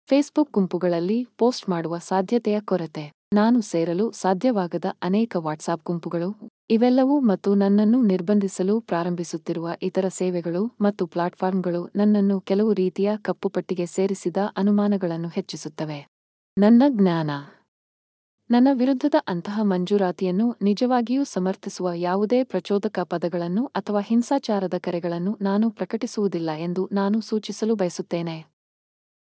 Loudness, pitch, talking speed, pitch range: -23 LUFS, 195 Hz, 100 wpm, 175-215 Hz